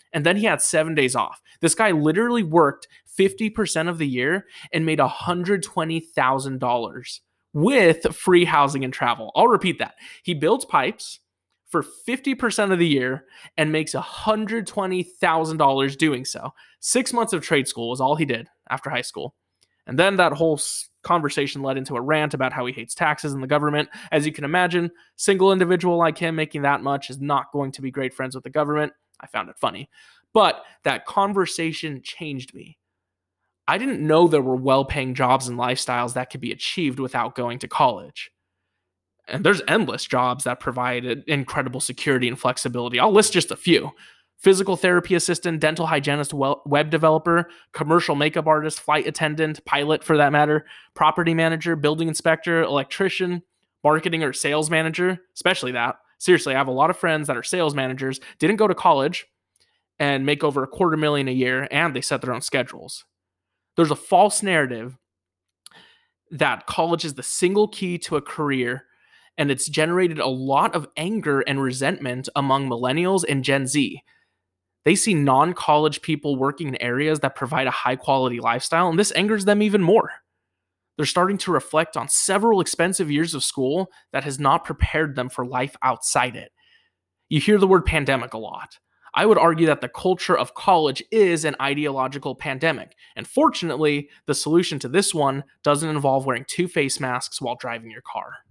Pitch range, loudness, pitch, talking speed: 130-170 Hz, -21 LUFS, 150 Hz, 175 wpm